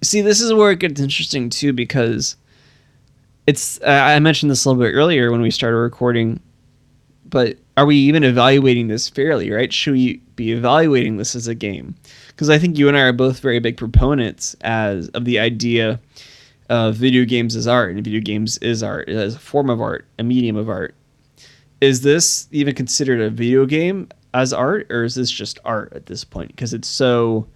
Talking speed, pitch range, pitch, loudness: 195 wpm, 115-140 Hz, 125 Hz, -16 LUFS